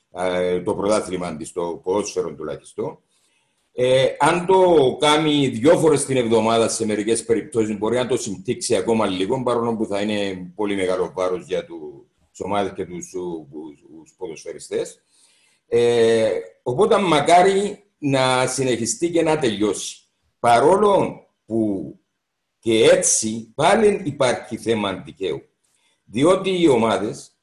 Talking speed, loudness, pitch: 120 wpm, -20 LUFS, 135 Hz